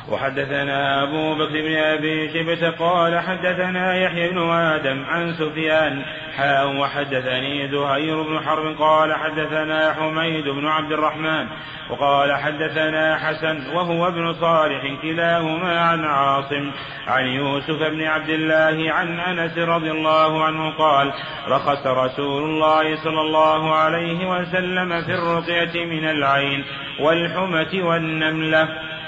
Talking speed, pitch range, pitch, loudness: 120 wpm, 145-165 Hz, 155 Hz, -20 LUFS